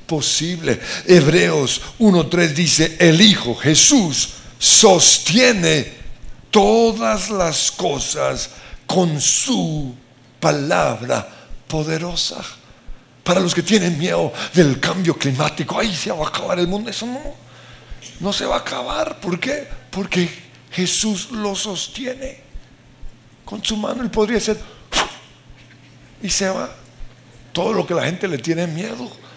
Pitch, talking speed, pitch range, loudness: 180 Hz, 125 wpm, 160-215 Hz, -16 LUFS